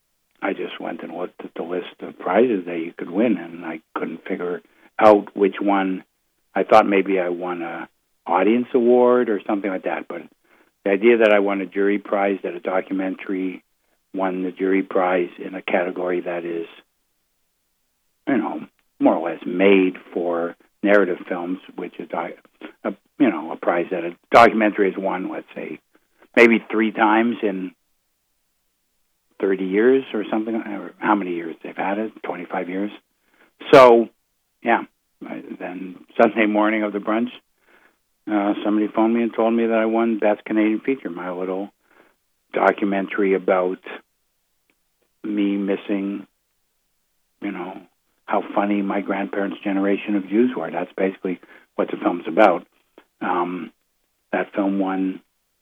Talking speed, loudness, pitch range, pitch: 150 wpm, -21 LUFS, 95-110 Hz, 100 Hz